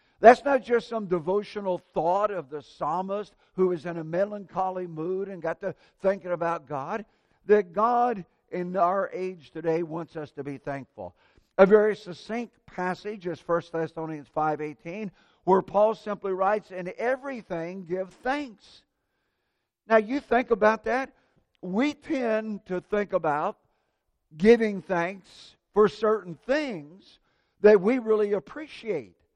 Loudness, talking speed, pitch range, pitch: -26 LUFS, 135 wpm, 170-215 Hz, 190 Hz